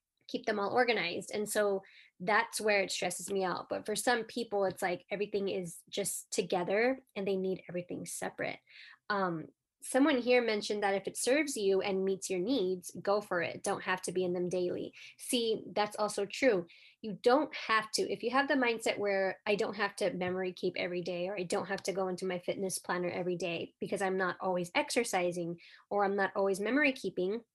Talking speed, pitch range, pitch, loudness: 205 wpm, 185-220 Hz, 195 Hz, -33 LUFS